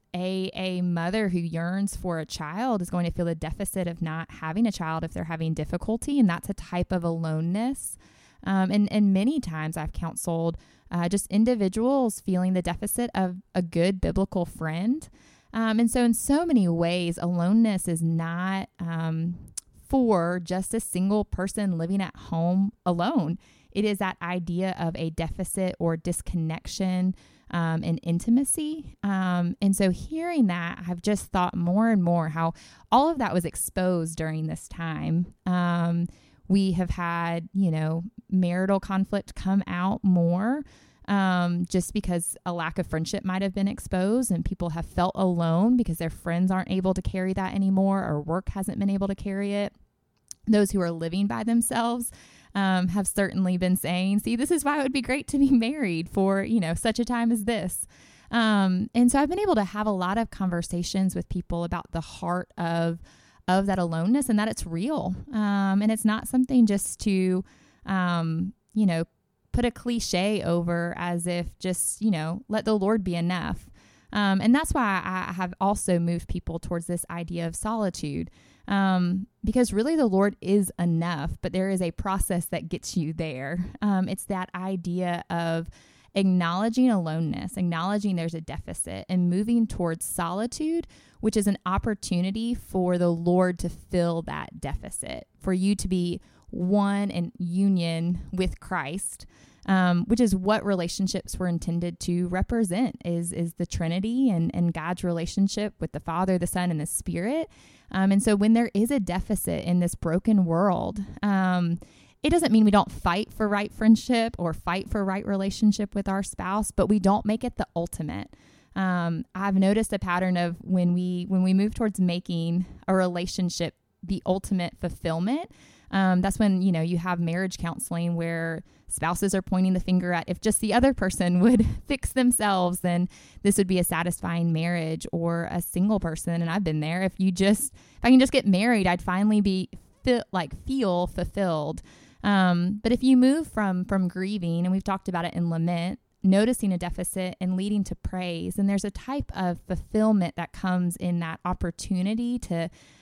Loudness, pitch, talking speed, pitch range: -26 LUFS, 185 Hz, 180 wpm, 175-205 Hz